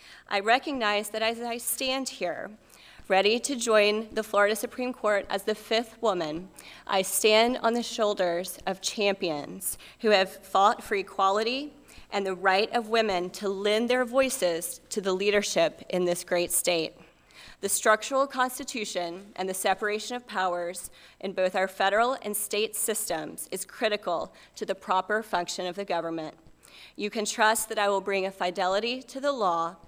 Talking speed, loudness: 165 wpm, -27 LUFS